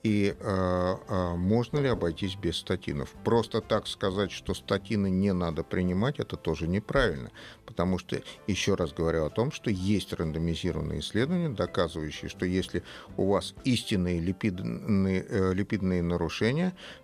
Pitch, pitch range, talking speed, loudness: 95 Hz, 85-105 Hz, 135 wpm, -29 LUFS